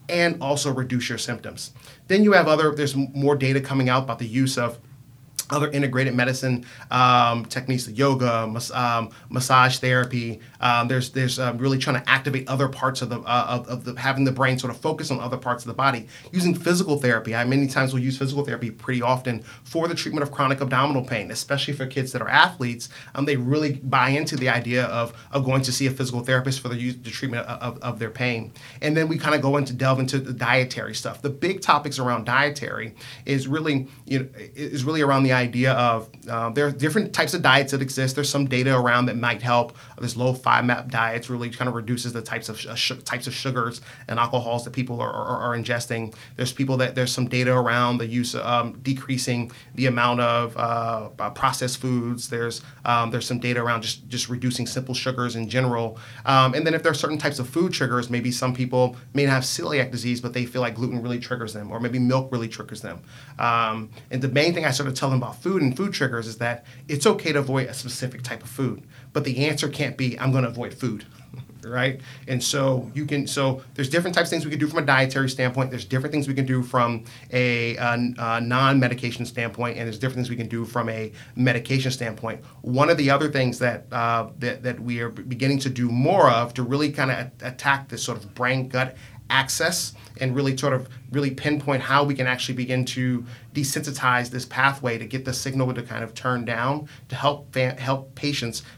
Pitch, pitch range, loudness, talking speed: 125 Hz, 120-135 Hz, -23 LUFS, 225 wpm